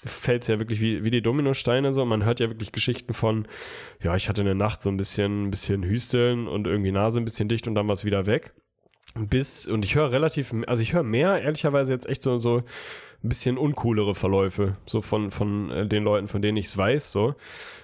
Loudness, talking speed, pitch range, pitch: -24 LUFS, 215 wpm, 100-125 Hz, 110 Hz